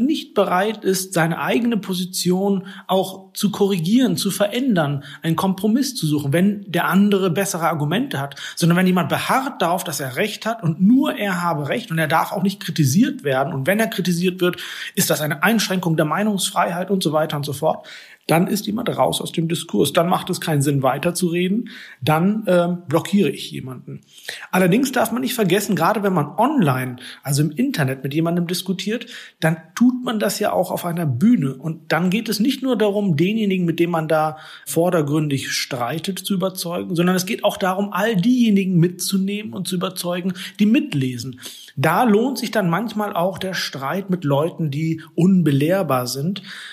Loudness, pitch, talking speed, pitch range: -20 LUFS, 185 Hz, 185 wpm, 160-205 Hz